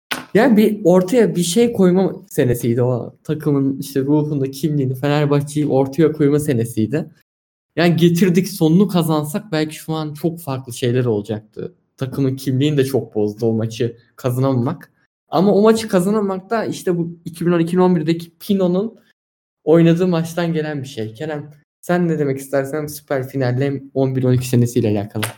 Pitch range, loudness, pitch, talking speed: 130-175 Hz, -18 LUFS, 150 Hz, 140 wpm